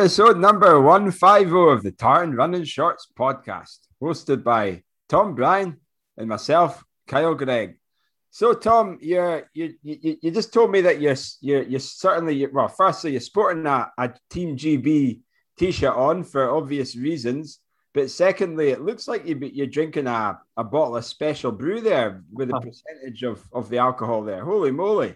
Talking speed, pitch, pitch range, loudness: 160 wpm, 150 Hz, 130-180 Hz, -21 LUFS